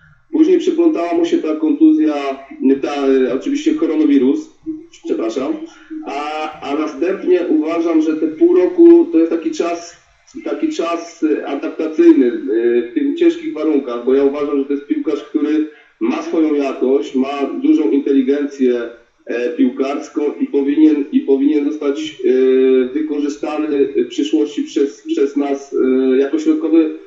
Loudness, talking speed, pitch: -16 LUFS, 125 wpm, 160 Hz